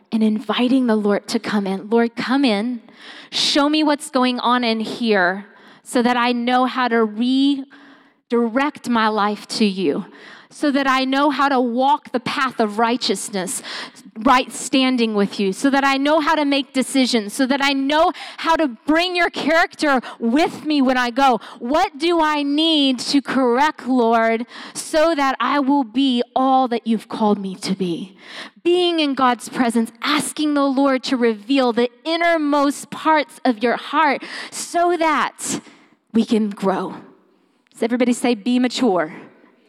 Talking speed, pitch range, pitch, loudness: 165 wpm, 230-280 Hz, 255 Hz, -18 LUFS